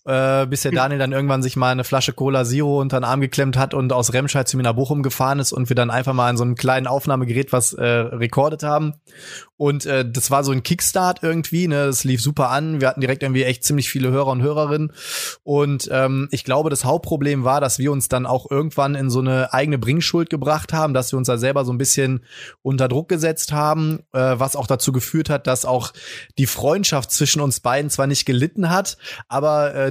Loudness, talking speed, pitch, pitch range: -19 LUFS, 230 wpm, 135 Hz, 130-145 Hz